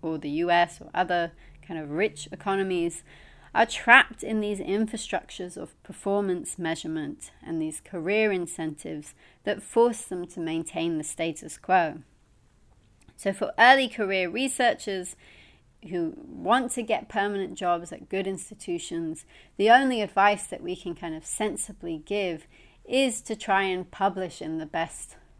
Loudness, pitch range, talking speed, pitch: -26 LUFS, 165-210 Hz, 145 wpm, 185 Hz